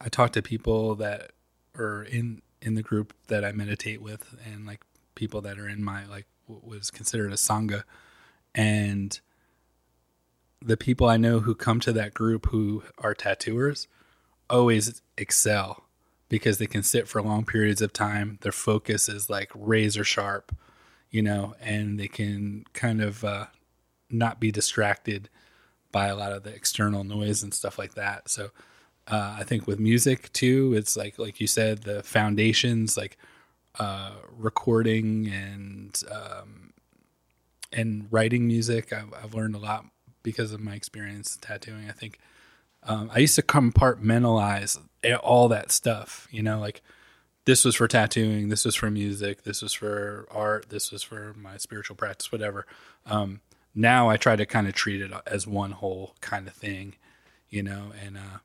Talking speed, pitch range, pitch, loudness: 165 wpm, 100-115 Hz, 105 Hz, -26 LUFS